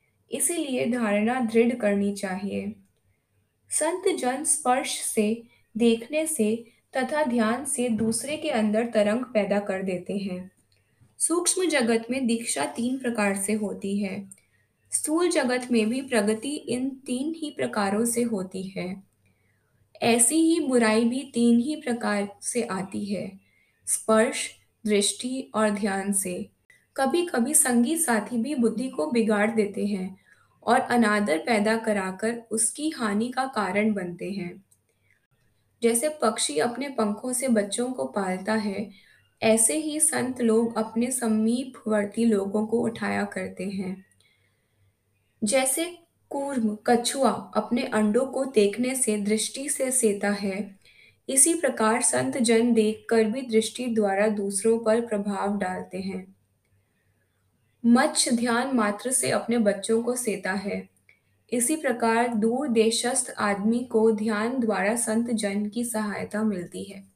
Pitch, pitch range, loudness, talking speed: 220 Hz, 200-245 Hz, -25 LUFS, 130 wpm